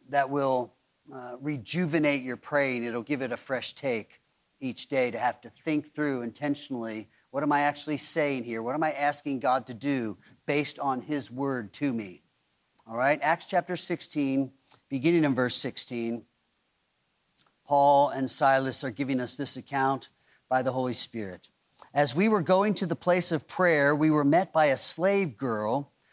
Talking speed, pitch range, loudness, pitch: 175 wpm, 125-150 Hz, -27 LUFS, 140 Hz